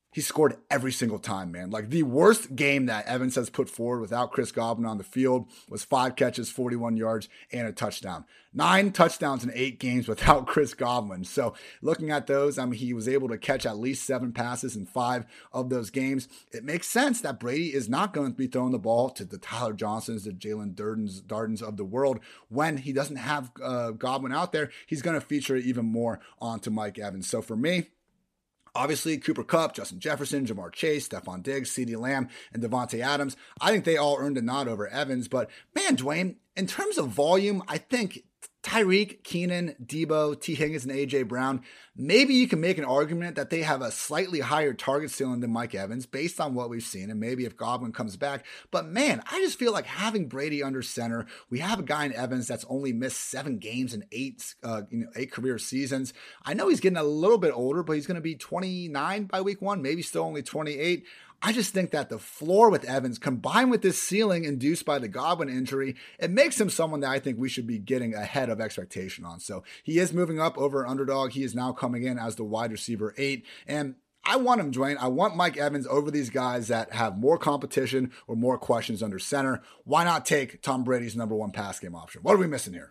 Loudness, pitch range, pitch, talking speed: -28 LUFS, 120-155 Hz, 135 Hz, 220 wpm